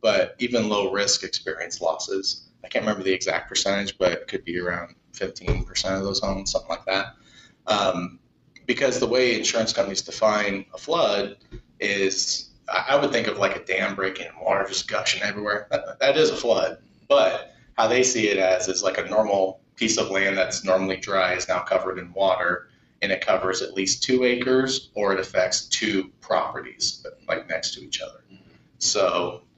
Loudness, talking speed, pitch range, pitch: -23 LUFS, 185 wpm, 95-110 Hz, 100 Hz